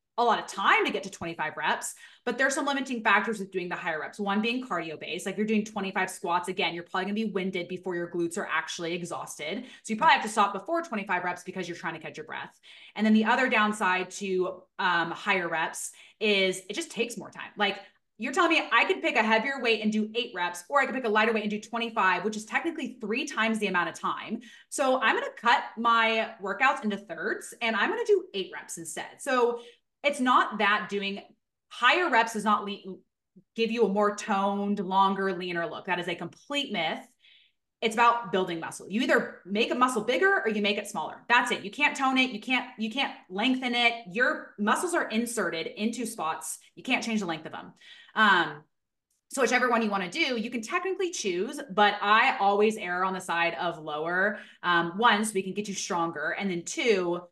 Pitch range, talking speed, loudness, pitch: 185-240 Hz, 225 wpm, -27 LUFS, 210 Hz